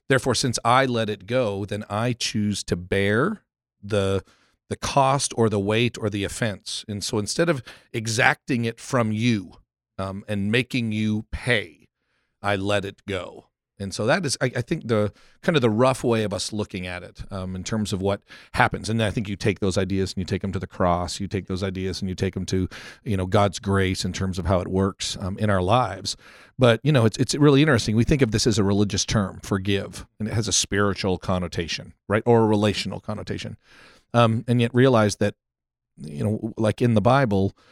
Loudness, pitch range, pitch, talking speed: -23 LUFS, 95-120 Hz, 105 Hz, 215 wpm